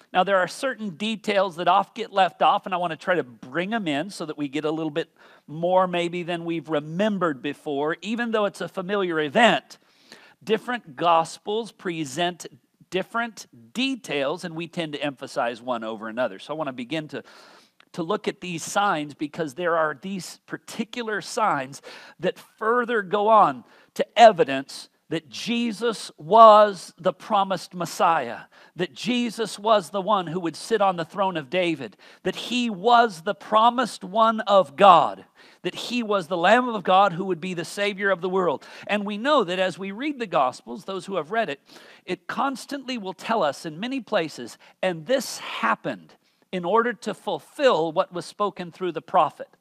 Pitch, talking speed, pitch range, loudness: 190 Hz, 185 wpm, 170-220 Hz, -23 LUFS